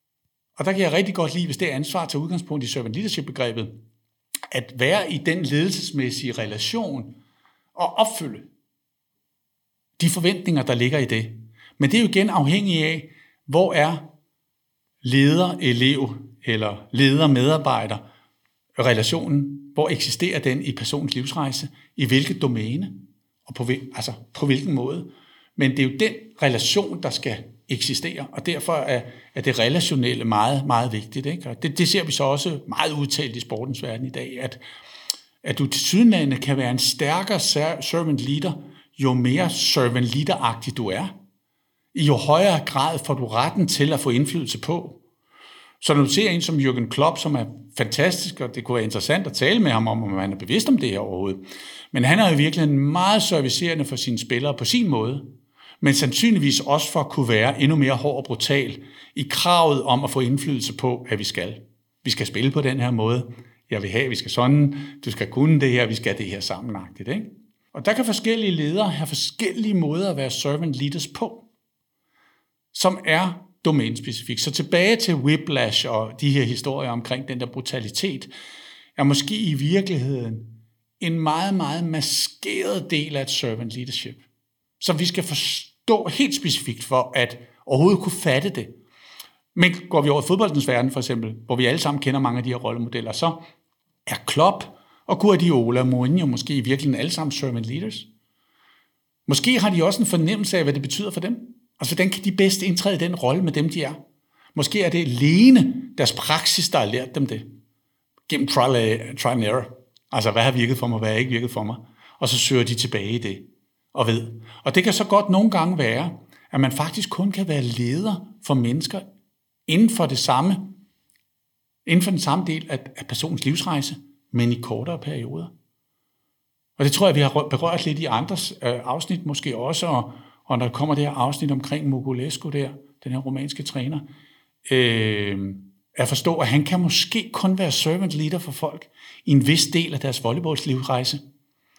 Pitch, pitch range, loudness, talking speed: 140 Hz, 125-165 Hz, -22 LUFS, 190 wpm